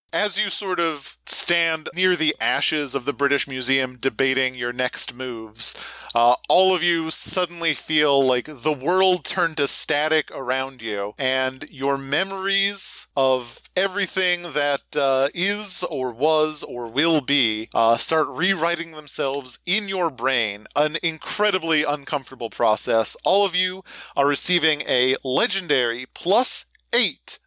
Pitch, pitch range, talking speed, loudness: 150 Hz, 130-175 Hz, 140 wpm, -20 LUFS